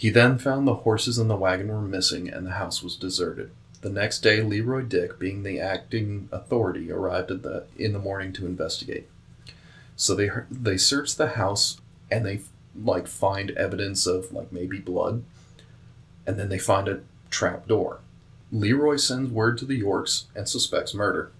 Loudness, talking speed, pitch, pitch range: -25 LUFS, 175 wpm, 100 Hz, 95-120 Hz